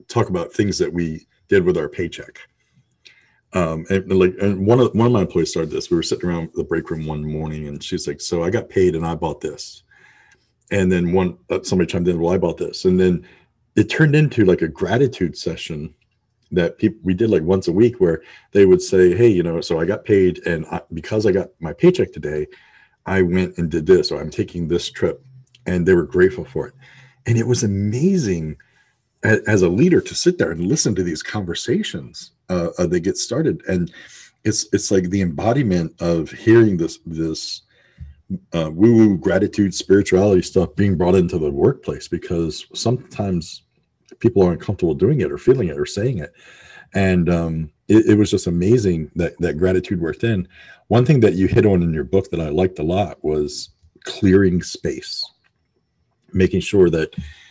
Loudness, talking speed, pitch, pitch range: -19 LUFS, 195 wpm, 95 Hz, 85-110 Hz